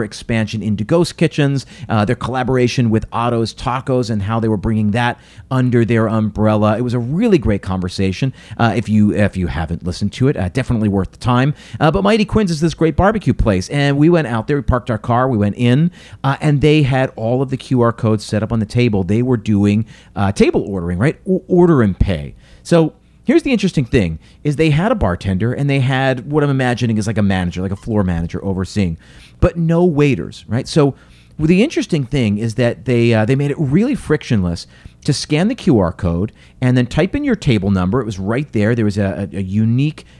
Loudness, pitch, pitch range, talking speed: -16 LUFS, 120 Hz, 105-145 Hz, 220 wpm